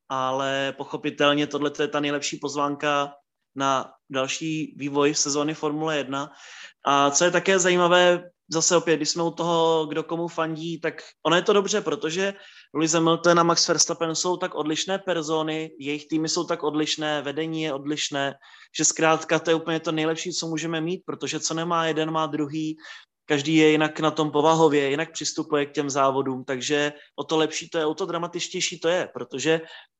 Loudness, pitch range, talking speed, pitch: -24 LUFS, 145-165 Hz, 180 wpm, 155 Hz